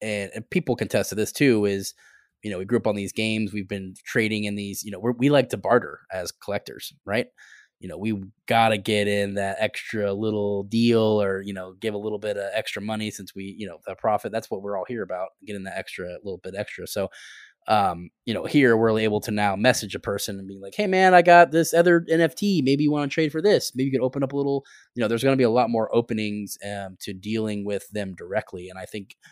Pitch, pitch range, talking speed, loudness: 105 Hz, 100-125 Hz, 250 wpm, -23 LUFS